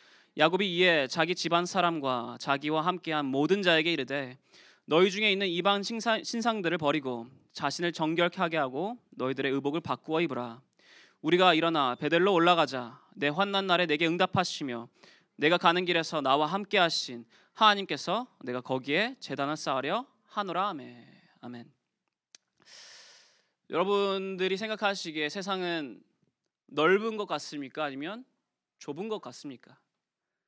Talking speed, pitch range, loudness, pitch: 310 characters per minute, 140-195 Hz, -28 LUFS, 170 Hz